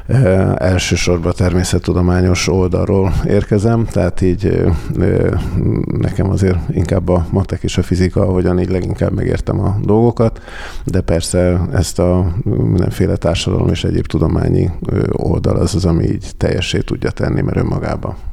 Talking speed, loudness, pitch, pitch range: 130 wpm, -15 LUFS, 95 Hz, 90-105 Hz